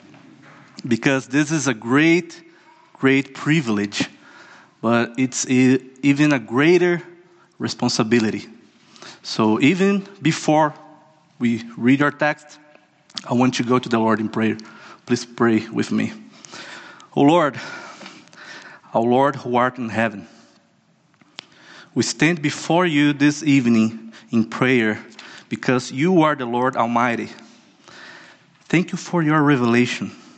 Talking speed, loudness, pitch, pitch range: 125 wpm, -19 LUFS, 130 Hz, 115-155 Hz